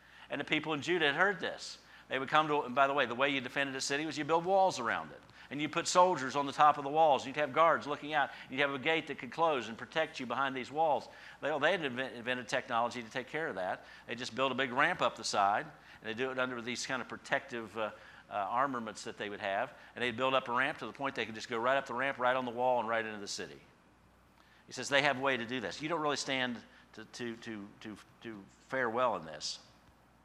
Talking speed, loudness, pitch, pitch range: 280 wpm, -33 LUFS, 135 Hz, 120-150 Hz